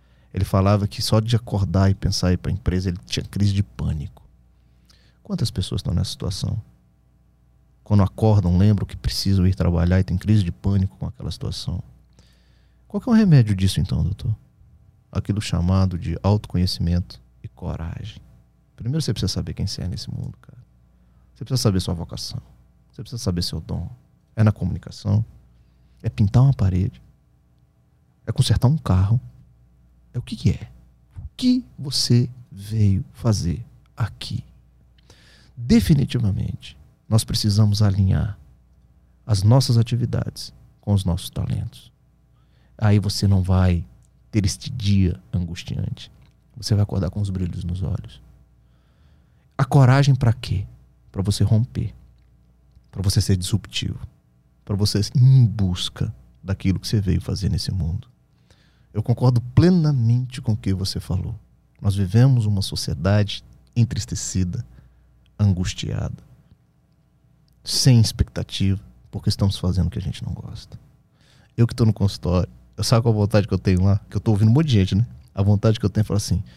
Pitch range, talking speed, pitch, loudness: 90-115 Hz, 155 wpm, 100 Hz, -21 LUFS